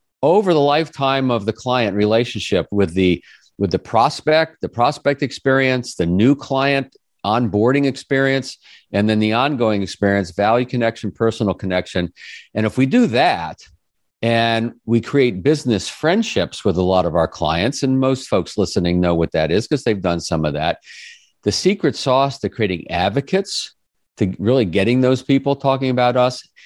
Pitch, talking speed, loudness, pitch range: 120 Hz, 165 wpm, -18 LUFS, 100-135 Hz